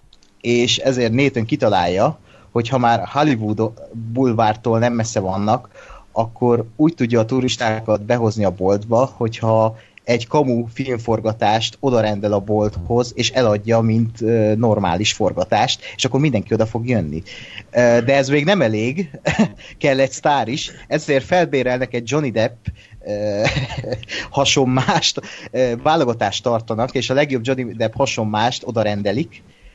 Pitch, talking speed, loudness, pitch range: 115 Hz, 135 wpm, -18 LUFS, 110-130 Hz